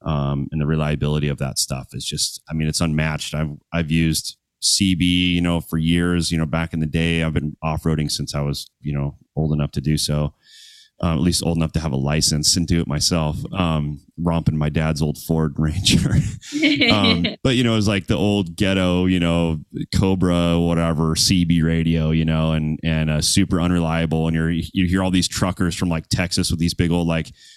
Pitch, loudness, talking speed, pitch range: 80 Hz, -20 LUFS, 210 wpm, 75-90 Hz